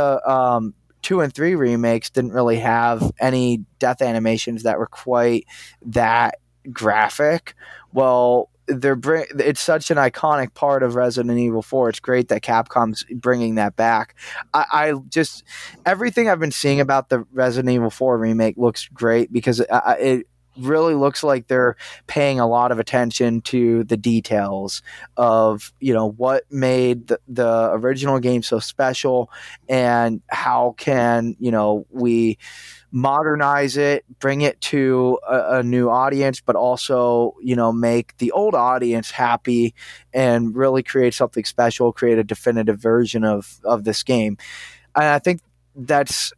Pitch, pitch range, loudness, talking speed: 125 Hz, 115-135 Hz, -19 LUFS, 155 wpm